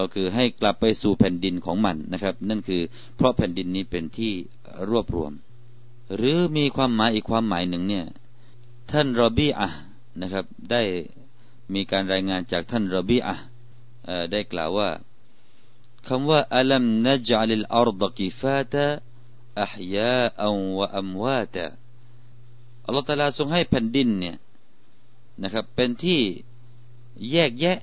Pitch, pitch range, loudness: 120 Hz, 95-125 Hz, -24 LUFS